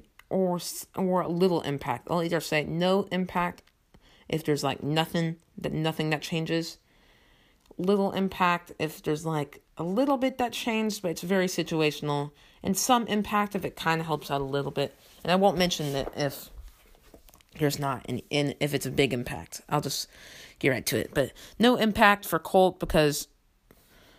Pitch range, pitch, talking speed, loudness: 145-190 Hz, 165 Hz, 175 wpm, -27 LUFS